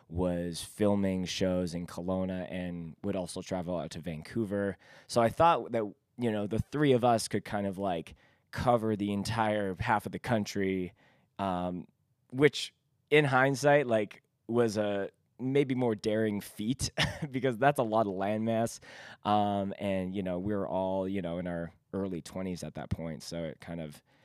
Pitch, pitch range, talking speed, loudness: 100 Hz, 90-120 Hz, 175 wpm, -31 LUFS